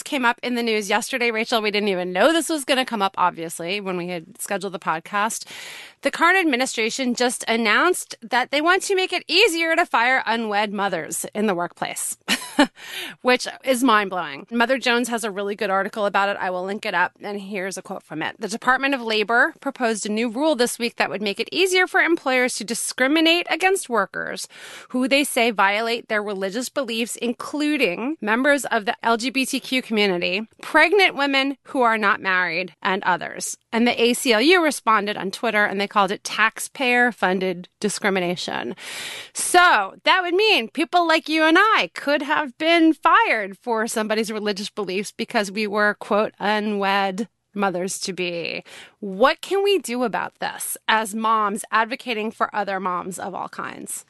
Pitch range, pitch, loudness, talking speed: 205-275 Hz, 230 Hz, -21 LUFS, 180 wpm